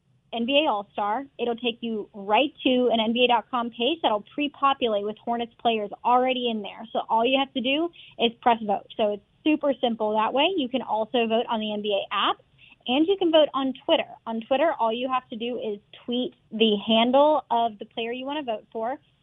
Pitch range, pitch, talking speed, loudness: 220-270 Hz, 235 Hz, 210 wpm, -25 LUFS